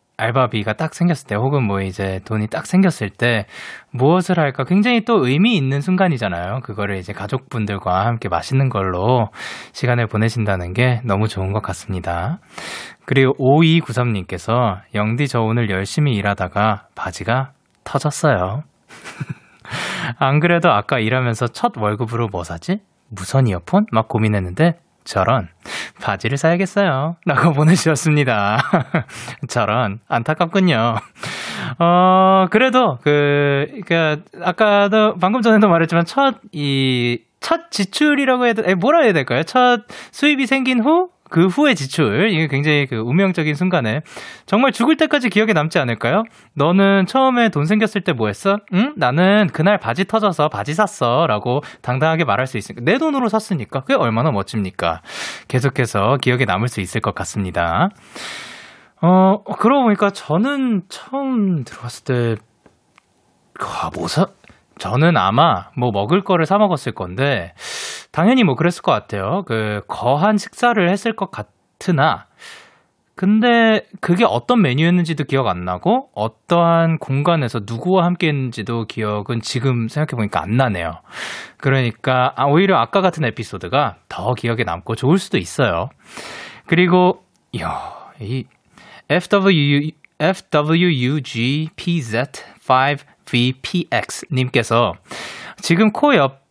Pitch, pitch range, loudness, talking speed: 145 Hz, 115-190 Hz, -17 LUFS, 290 characters per minute